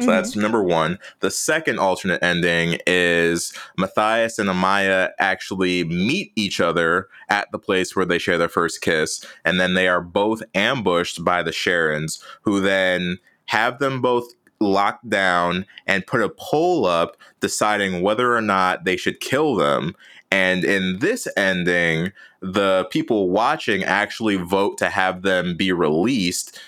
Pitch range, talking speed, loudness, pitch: 90-100 Hz, 155 wpm, -20 LUFS, 95 Hz